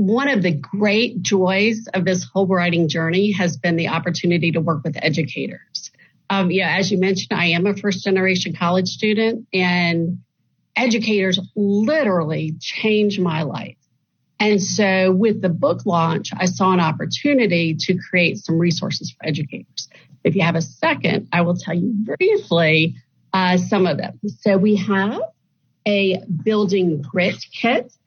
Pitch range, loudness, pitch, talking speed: 170-205 Hz, -19 LUFS, 185 Hz, 155 wpm